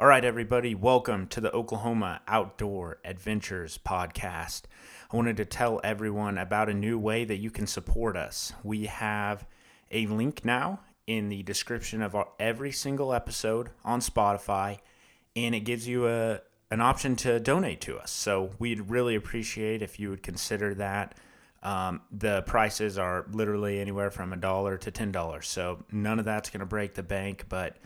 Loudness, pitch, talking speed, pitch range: -30 LUFS, 105 Hz, 175 wpm, 100-115 Hz